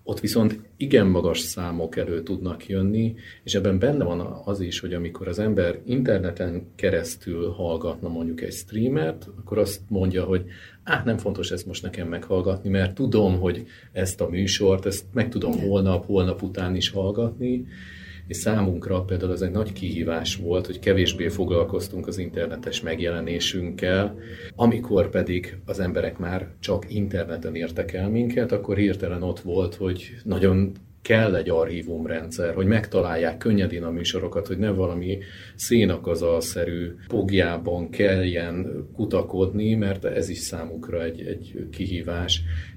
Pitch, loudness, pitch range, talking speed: 95 Hz, -25 LUFS, 85-100 Hz, 140 wpm